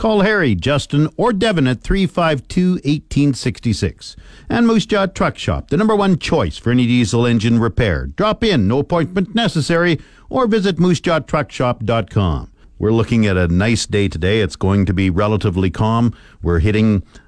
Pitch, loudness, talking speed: 120 Hz, -16 LUFS, 155 wpm